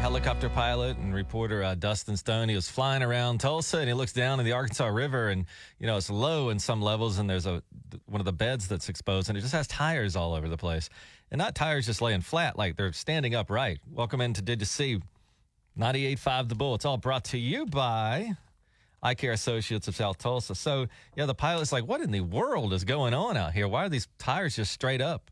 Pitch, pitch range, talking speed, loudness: 120 Hz, 100-135 Hz, 230 wpm, -30 LUFS